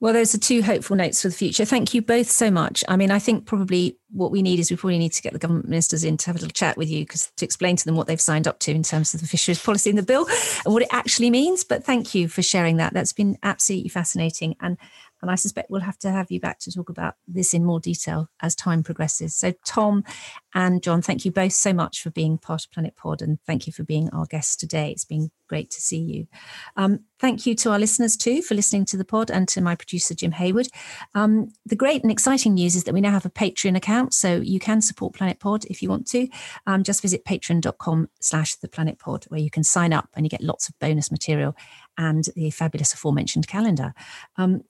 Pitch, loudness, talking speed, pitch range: 185 Hz, -22 LUFS, 255 wpm, 160-210 Hz